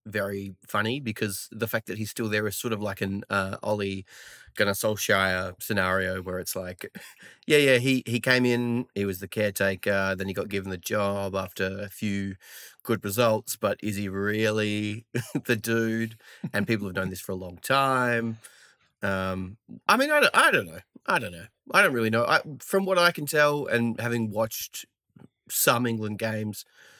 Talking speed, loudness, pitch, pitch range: 190 wpm, -26 LUFS, 105 Hz, 95-120 Hz